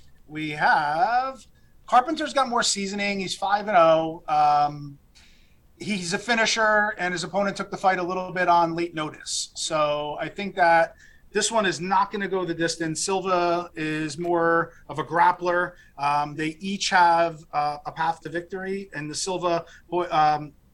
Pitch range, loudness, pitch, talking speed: 155-195 Hz, -24 LUFS, 175 Hz, 170 wpm